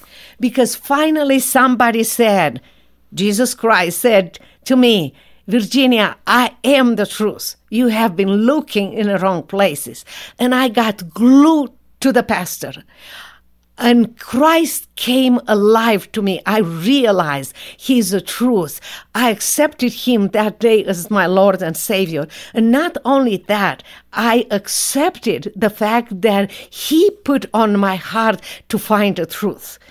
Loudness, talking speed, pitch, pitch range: -15 LUFS, 135 wpm, 225 Hz, 195-250 Hz